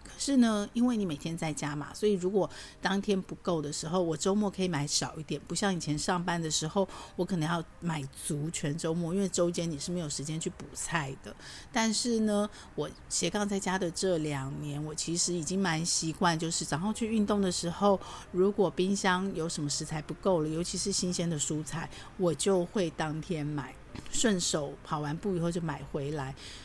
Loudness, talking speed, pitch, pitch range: -31 LUFS, 290 characters per minute, 175 Hz, 155-195 Hz